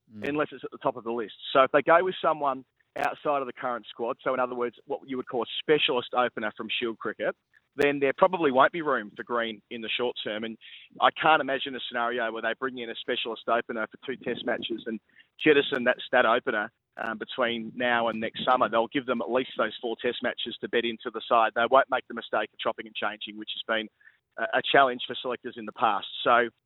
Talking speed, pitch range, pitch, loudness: 240 wpm, 115-135 Hz, 125 Hz, -27 LUFS